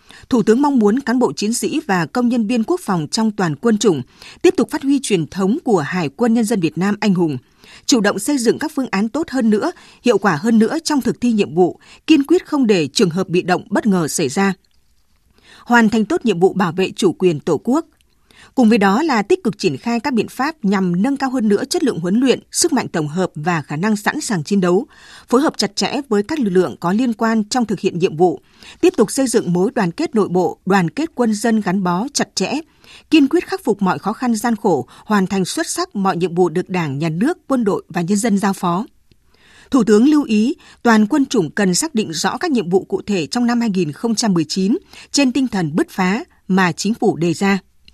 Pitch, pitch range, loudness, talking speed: 215 Hz, 185-255 Hz, -17 LUFS, 245 wpm